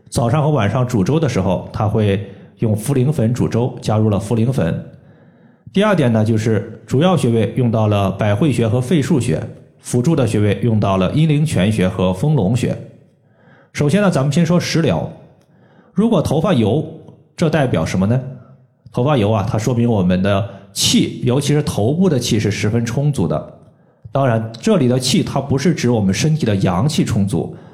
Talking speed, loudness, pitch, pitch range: 265 characters per minute, -16 LUFS, 125 Hz, 110-150 Hz